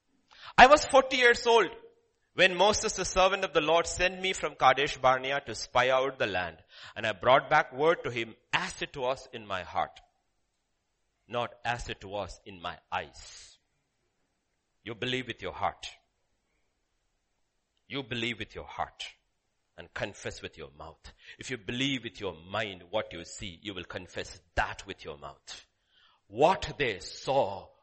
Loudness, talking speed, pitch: -28 LUFS, 165 wpm, 125 Hz